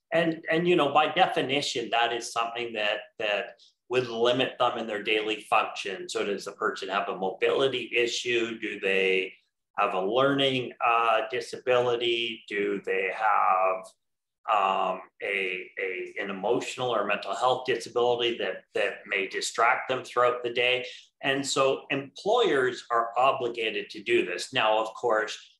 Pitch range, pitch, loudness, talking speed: 115-185 Hz, 125 Hz, -27 LUFS, 150 wpm